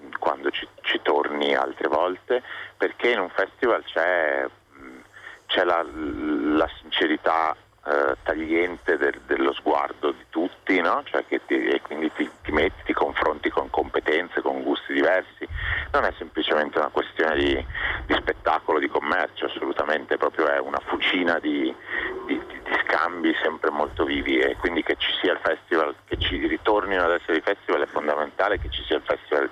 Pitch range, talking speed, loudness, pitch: 330-455 Hz, 165 wpm, -24 LUFS, 375 Hz